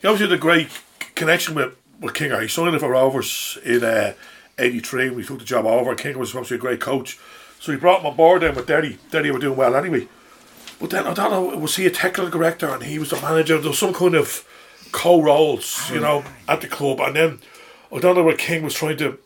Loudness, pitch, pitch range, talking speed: -19 LUFS, 160 Hz, 140-180 Hz, 250 wpm